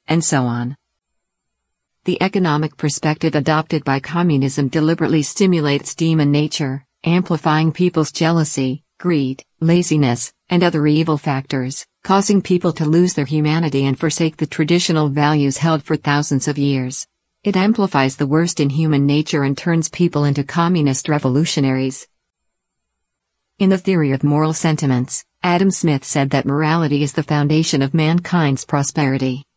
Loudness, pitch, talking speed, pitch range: -17 LUFS, 155 Hz, 140 wpm, 140-165 Hz